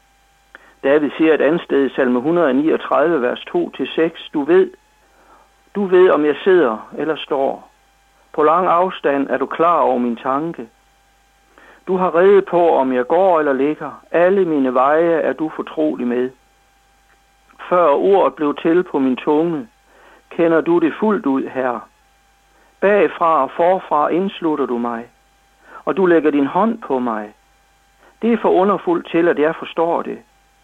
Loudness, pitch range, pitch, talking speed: -16 LUFS, 140-185 Hz, 165 Hz, 155 wpm